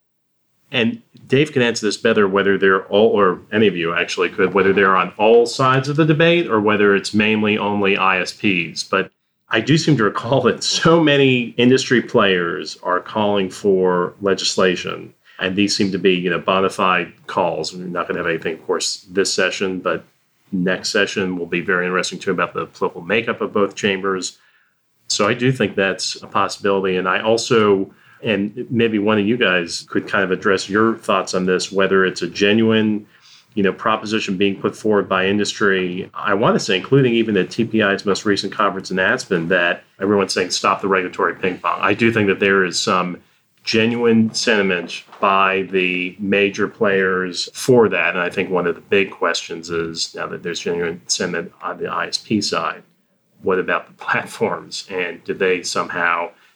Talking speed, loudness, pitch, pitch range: 190 wpm, -18 LUFS, 100 Hz, 95-115 Hz